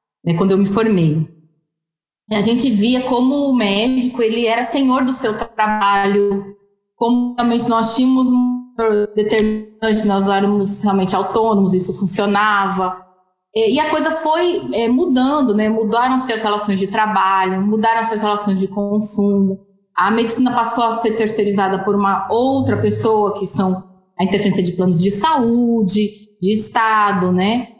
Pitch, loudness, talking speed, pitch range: 210 Hz, -15 LUFS, 140 wpm, 195-235 Hz